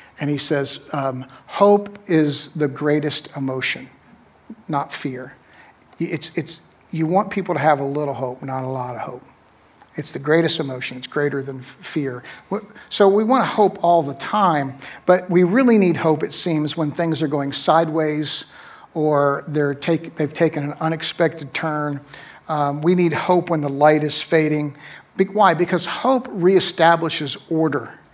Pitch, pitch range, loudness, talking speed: 155 Hz, 145-170 Hz, -20 LUFS, 165 wpm